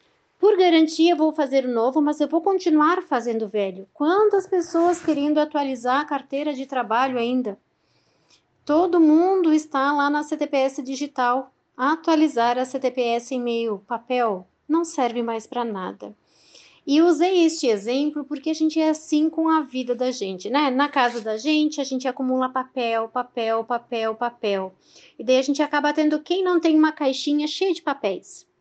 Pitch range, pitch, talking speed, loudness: 245-315 Hz, 280 Hz, 170 wpm, -22 LUFS